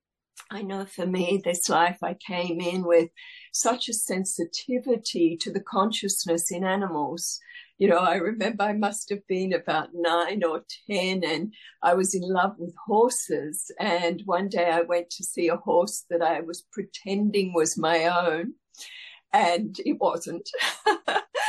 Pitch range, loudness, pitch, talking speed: 170-210 Hz, -26 LUFS, 185 Hz, 155 wpm